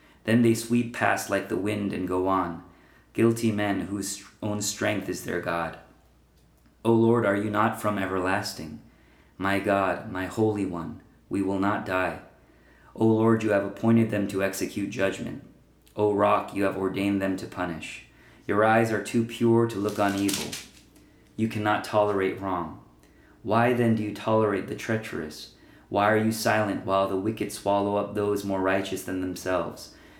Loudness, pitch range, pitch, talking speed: -26 LUFS, 95-110 Hz, 100 Hz, 170 wpm